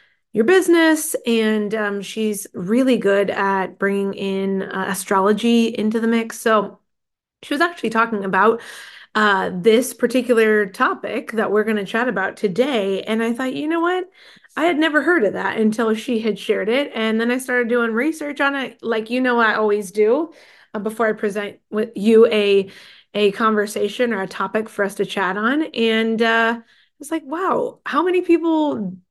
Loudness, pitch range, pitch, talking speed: -19 LUFS, 205-250 Hz, 225 Hz, 185 wpm